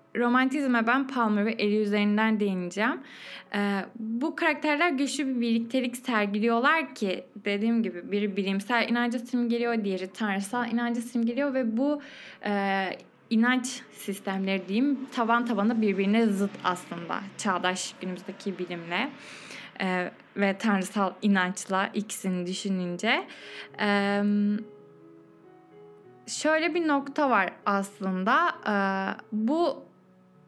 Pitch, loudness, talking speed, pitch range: 210 Hz, -27 LUFS, 105 wpm, 195-245 Hz